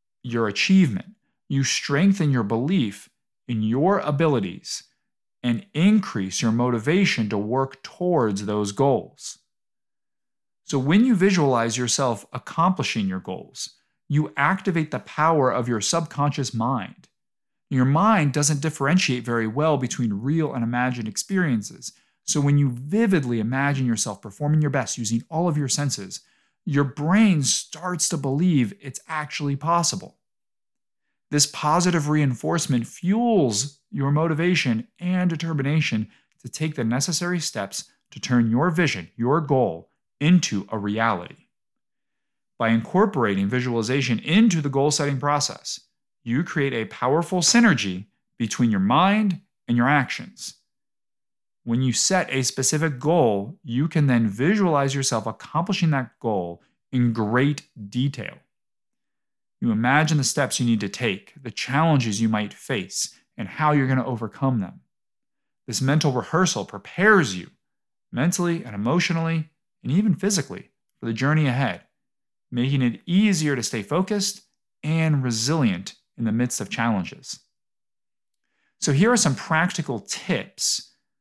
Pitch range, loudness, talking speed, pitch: 120-165 Hz, -22 LUFS, 130 wpm, 140 Hz